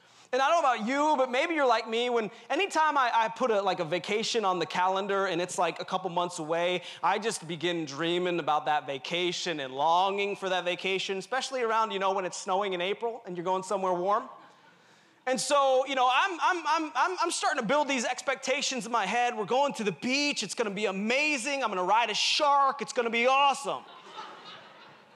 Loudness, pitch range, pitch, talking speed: -28 LUFS, 180-260 Hz, 220 Hz, 220 wpm